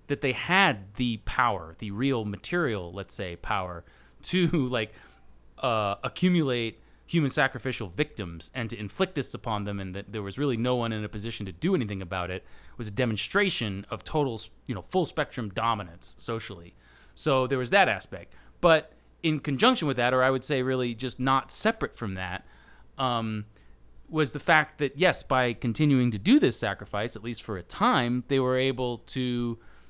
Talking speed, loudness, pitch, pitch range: 185 wpm, -27 LUFS, 120 Hz, 100-135 Hz